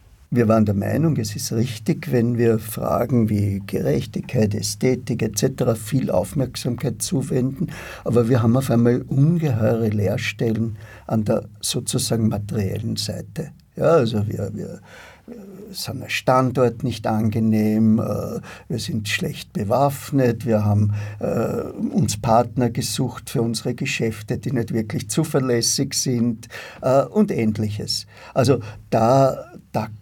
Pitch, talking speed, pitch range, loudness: 115 Hz, 120 wpm, 110-130 Hz, -21 LUFS